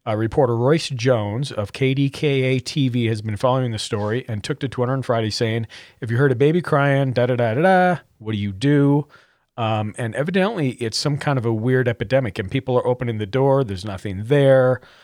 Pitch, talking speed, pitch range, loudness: 125 Hz, 195 wpm, 115-140 Hz, -20 LUFS